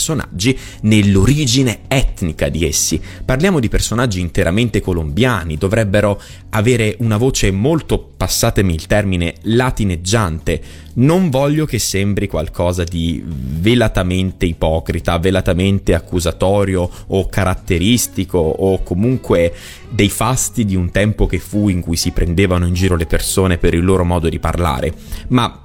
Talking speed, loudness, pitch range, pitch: 125 wpm, -16 LUFS, 85-110 Hz, 95 Hz